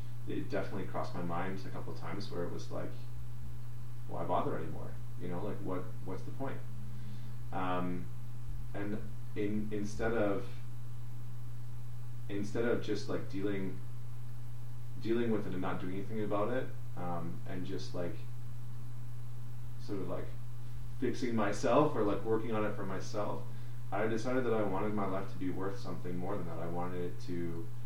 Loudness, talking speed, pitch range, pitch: -39 LUFS, 165 wpm, 100-120 Hz, 120 Hz